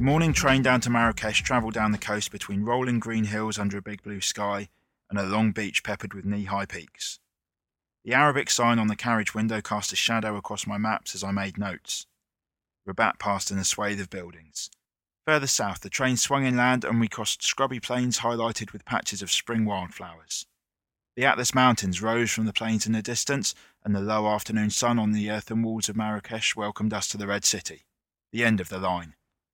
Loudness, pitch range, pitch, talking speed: -26 LUFS, 100-115 Hz, 110 Hz, 205 wpm